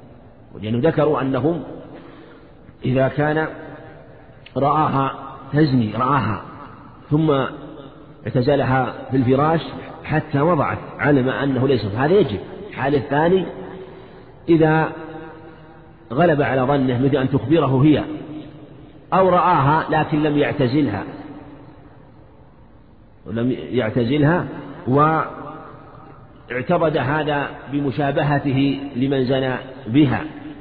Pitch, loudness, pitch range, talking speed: 145 Hz, -19 LUFS, 130-155 Hz, 85 wpm